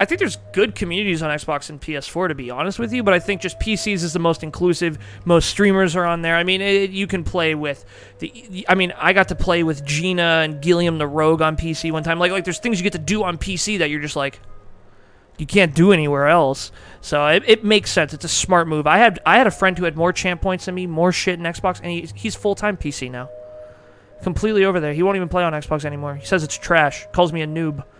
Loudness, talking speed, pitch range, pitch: -19 LUFS, 260 wpm, 150-185 Hz, 170 Hz